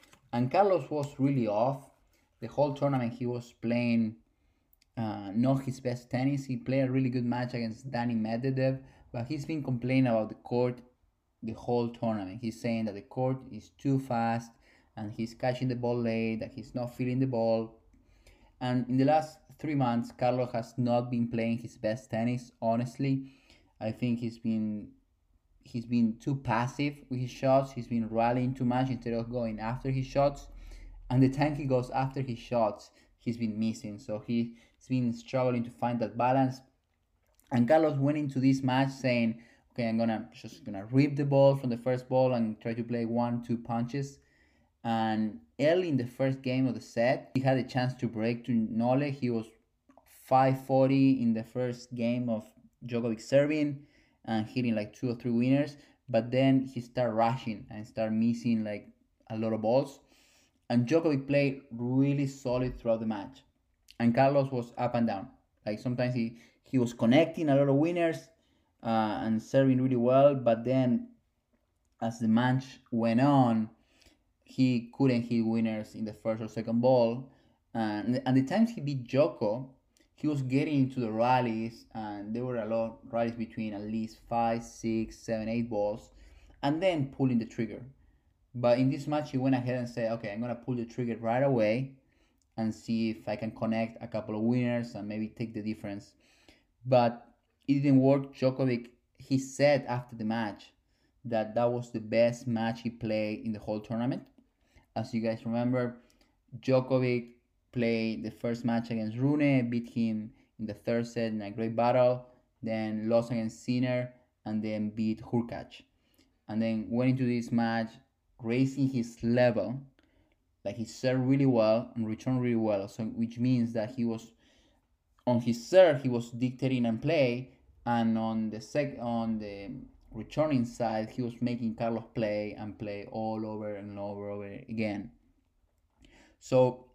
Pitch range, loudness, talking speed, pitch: 110-130 Hz, -30 LUFS, 175 wpm, 120 Hz